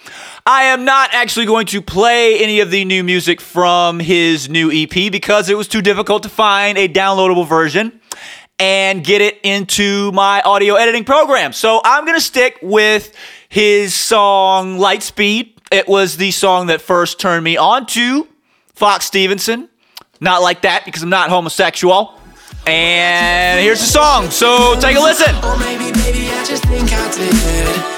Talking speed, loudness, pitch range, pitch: 150 wpm, -12 LUFS, 180-225 Hz, 200 Hz